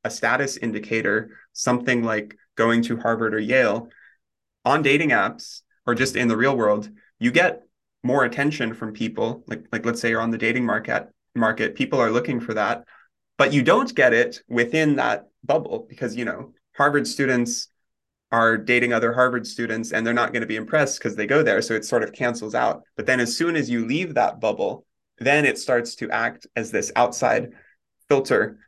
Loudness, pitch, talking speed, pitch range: -22 LUFS, 115 Hz, 195 wpm, 115-125 Hz